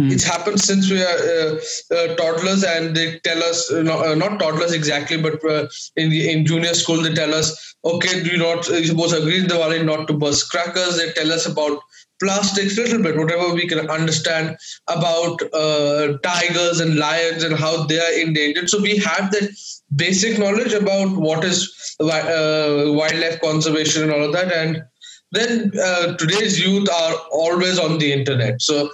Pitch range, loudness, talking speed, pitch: 155-185 Hz, -18 LUFS, 185 wpm, 165 Hz